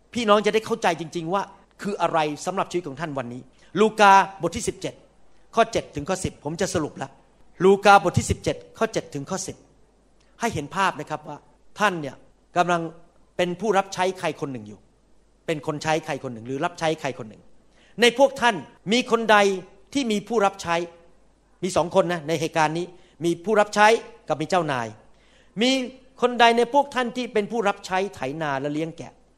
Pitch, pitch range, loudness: 180 Hz, 155-210 Hz, -23 LUFS